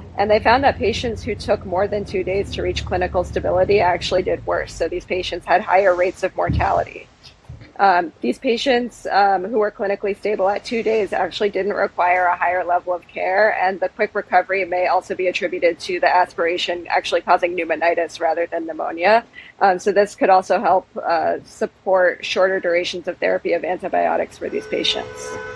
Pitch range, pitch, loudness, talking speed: 175-205 Hz, 185 Hz, -19 LUFS, 185 wpm